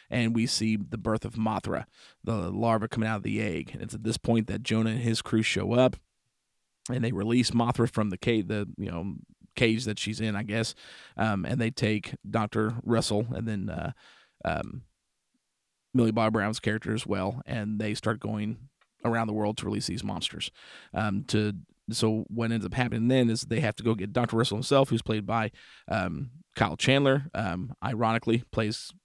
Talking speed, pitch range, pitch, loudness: 195 wpm, 105-115 Hz, 110 Hz, -29 LUFS